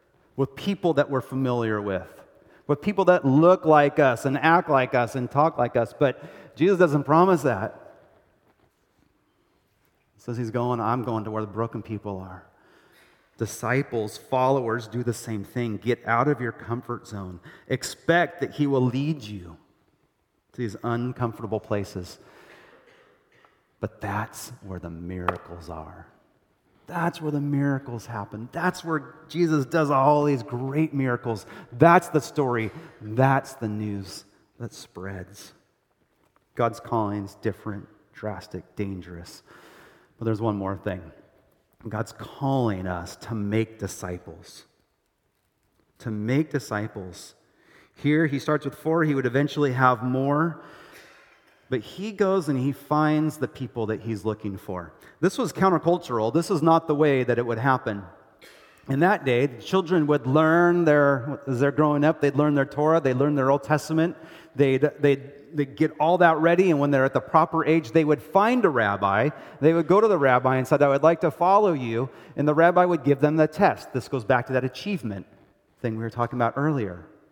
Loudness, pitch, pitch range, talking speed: -24 LUFS, 130 Hz, 110-155 Hz, 165 wpm